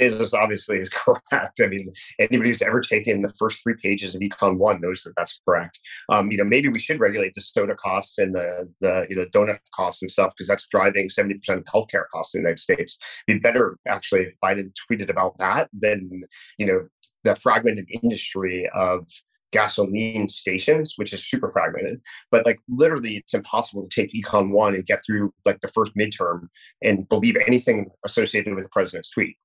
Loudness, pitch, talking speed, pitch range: -22 LUFS, 100 Hz, 200 wpm, 95-110 Hz